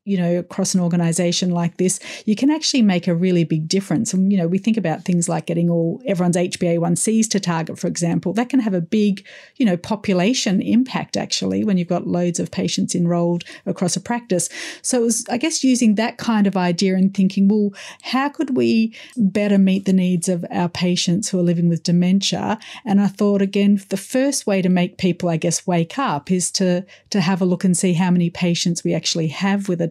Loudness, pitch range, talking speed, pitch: -19 LUFS, 175-210 Hz, 220 wpm, 185 Hz